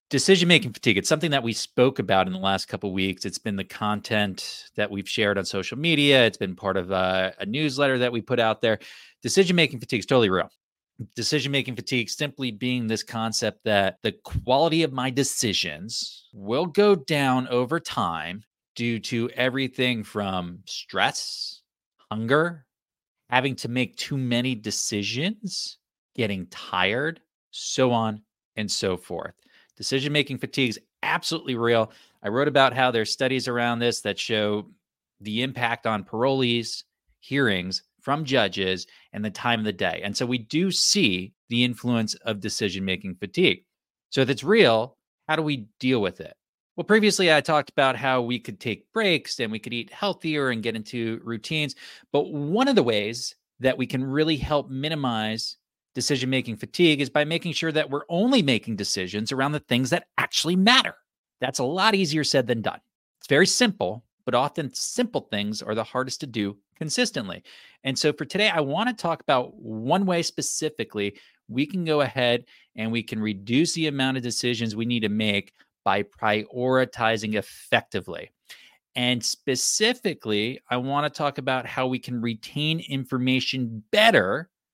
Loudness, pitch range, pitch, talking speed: -24 LUFS, 110-145 Hz, 125 Hz, 170 wpm